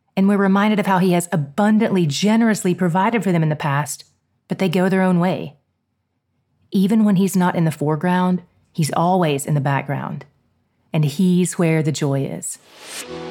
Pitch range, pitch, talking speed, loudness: 145-190 Hz, 175 Hz, 175 wpm, -18 LUFS